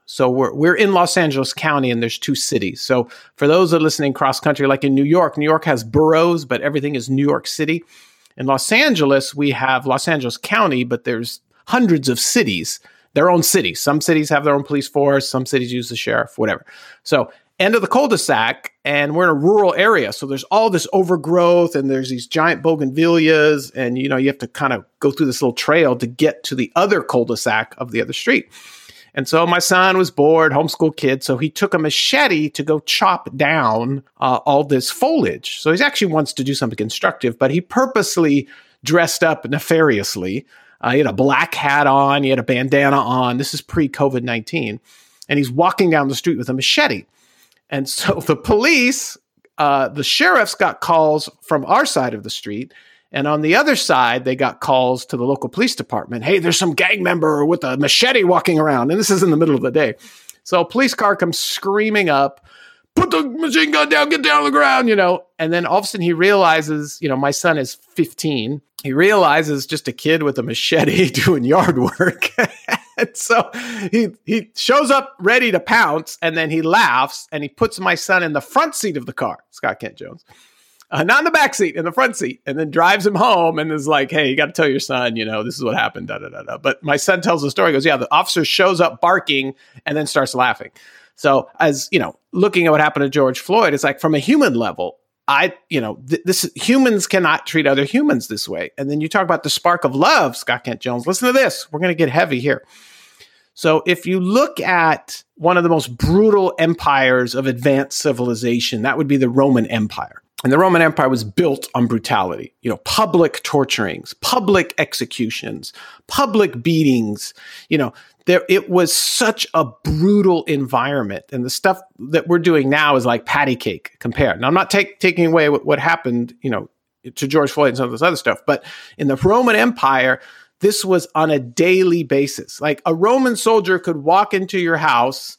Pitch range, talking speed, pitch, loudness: 135-180 Hz, 215 wpm, 155 Hz, -16 LUFS